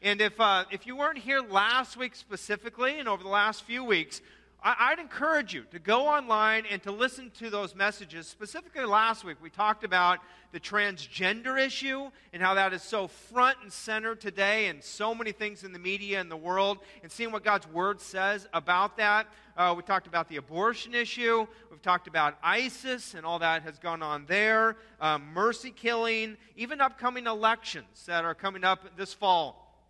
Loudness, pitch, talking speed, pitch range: -28 LUFS, 205 Hz, 190 wpm, 185-230 Hz